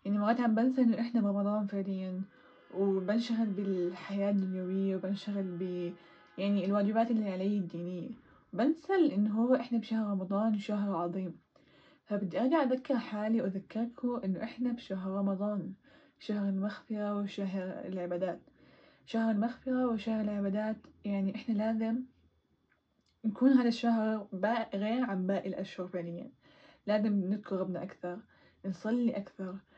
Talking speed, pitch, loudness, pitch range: 120 wpm, 205 Hz, -33 LUFS, 190-230 Hz